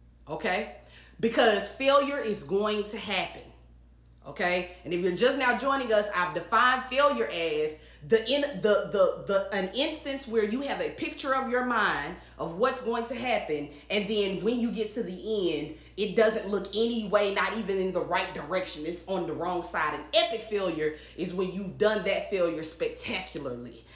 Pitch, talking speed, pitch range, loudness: 210 Hz, 185 wpm, 180-240 Hz, -28 LUFS